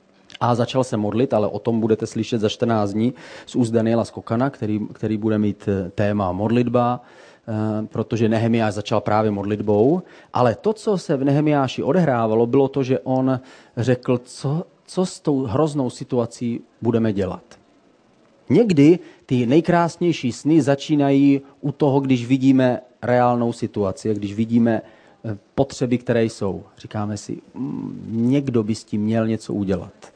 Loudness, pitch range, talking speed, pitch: -21 LUFS, 110-135 Hz, 145 wpm, 120 Hz